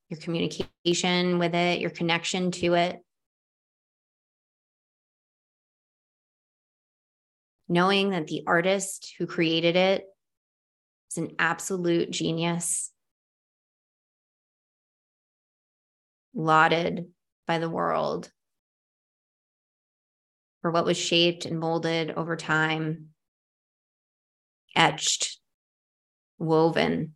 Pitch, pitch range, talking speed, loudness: 170 Hz, 160-175 Hz, 75 wpm, -25 LUFS